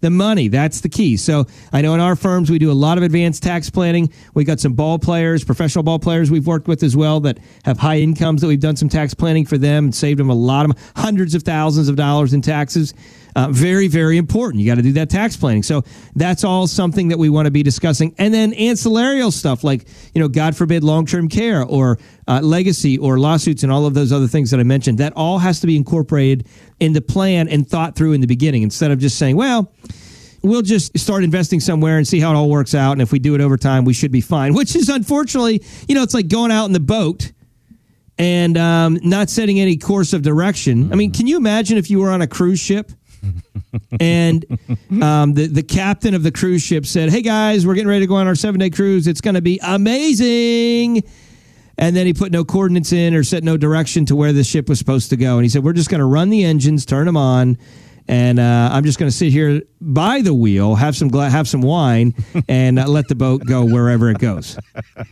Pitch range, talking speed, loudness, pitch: 140-180 Hz, 245 wpm, -15 LUFS, 155 Hz